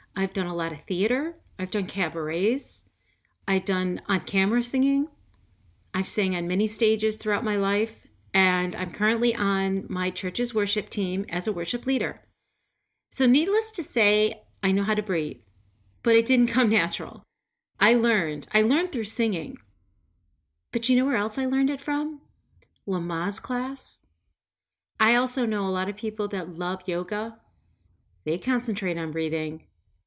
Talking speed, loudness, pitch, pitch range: 160 wpm, -26 LUFS, 195 Hz, 165-230 Hz